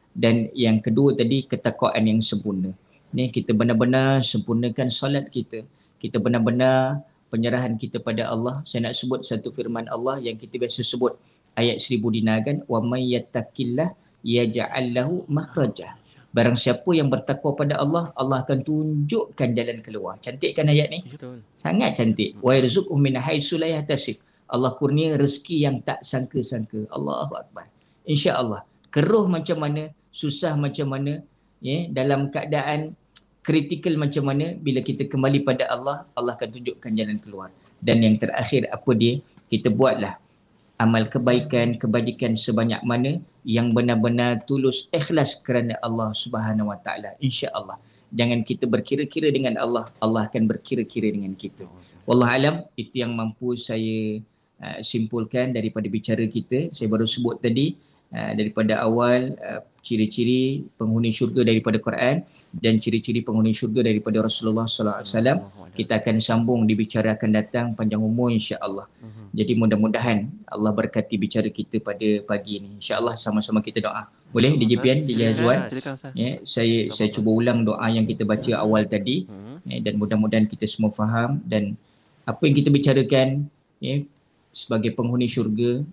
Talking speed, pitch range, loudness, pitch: 145 wpm, 110-135 Hz, -23 LUFS, 120 Hz